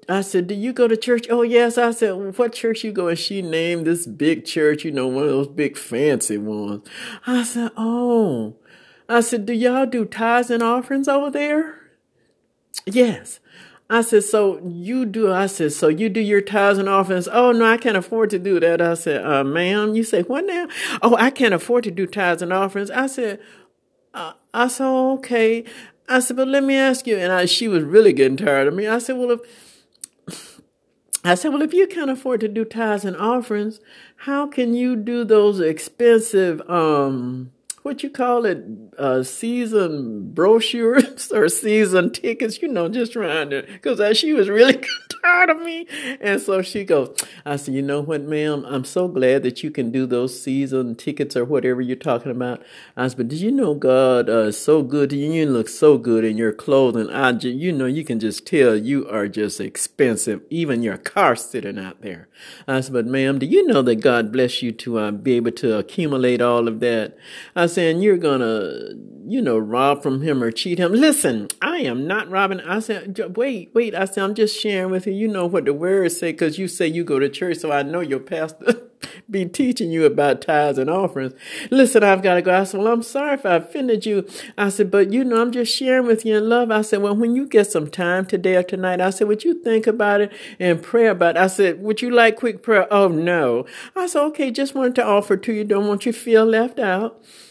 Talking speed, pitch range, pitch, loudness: 220 wpm, 150-235 Hz, 200 Hz, -19 LUFS